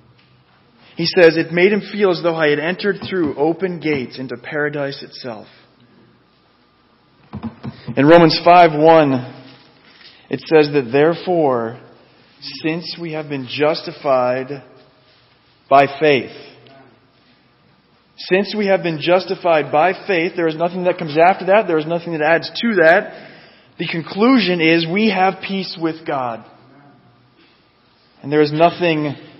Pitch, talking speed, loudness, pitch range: 160 Hz, 130 wpm, -16 LUFS, 140-175 Hz